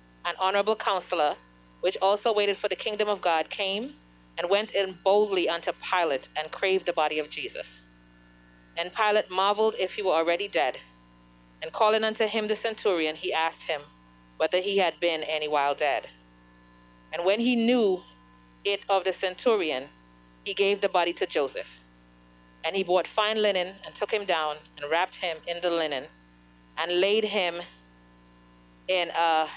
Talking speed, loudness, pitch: 165 wpm, -27 LUFS, 170 Hz